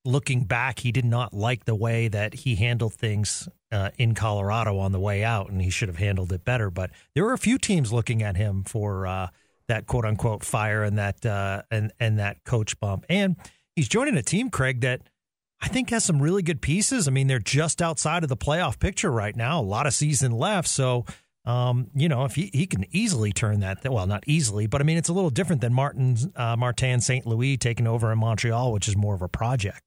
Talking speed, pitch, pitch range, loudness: 235 wpm, 120 Hz, 105-140 Hz, -25 LUFS